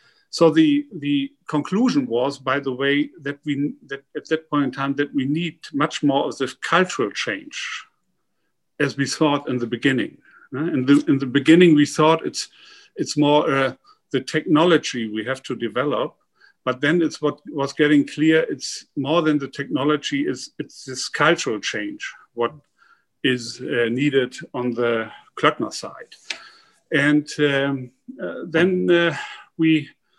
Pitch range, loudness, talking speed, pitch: 135-160 Hz, -21 LUFS, 155 wpm, 145 Hz